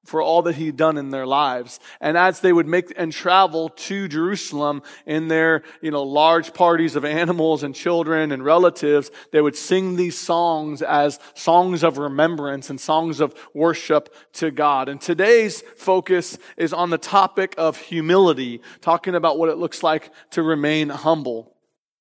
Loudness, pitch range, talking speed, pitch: -20 LUFS, 150-175 Hz, 170 wpm, 160 Hz